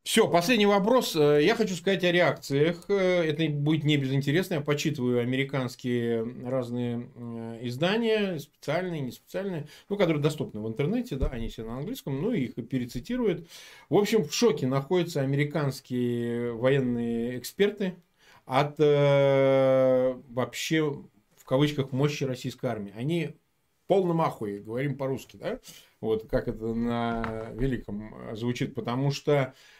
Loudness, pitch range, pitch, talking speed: -27 LUFS, 120-170 Hz, 135 Hz, 130 wpm